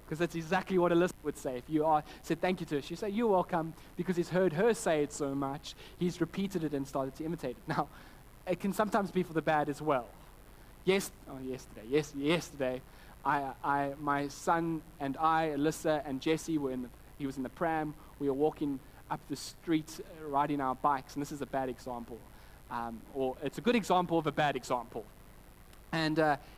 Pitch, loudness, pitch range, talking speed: 150 Hz, -33 LUFS, 135-165 Hz, 210 wpm